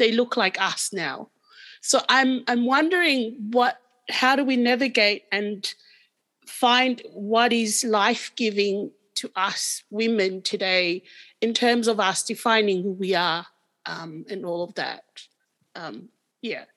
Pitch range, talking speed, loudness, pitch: 200-250 Hz, 135 wpm, -22 LUFS, 225 Hz